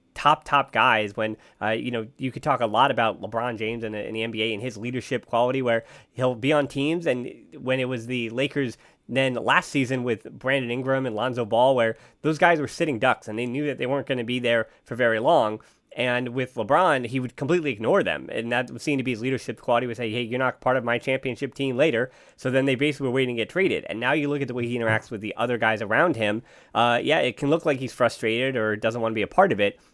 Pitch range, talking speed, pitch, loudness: 115-135 Hz, 265 wpm, 125 Hz, -24 LUFS